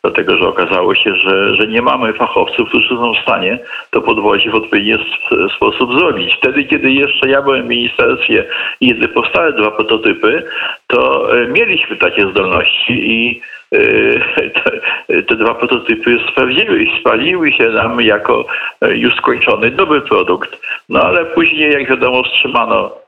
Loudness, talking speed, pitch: -11 LUFS, 145 wpm, 370 Hz